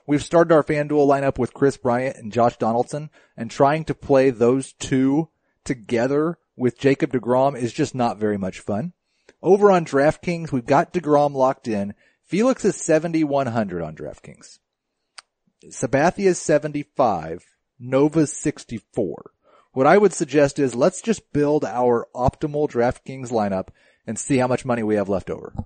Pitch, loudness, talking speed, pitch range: 140 Hz, -21 LUFS, 165 wpm, 120-155 Hz